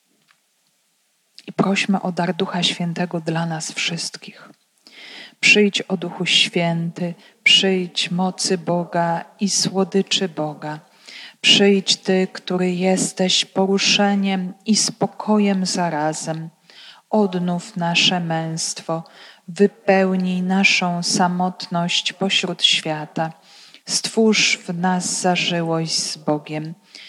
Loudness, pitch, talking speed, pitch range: -19 LUFS, 185 Hz, 90 wpm, 170-200 Hz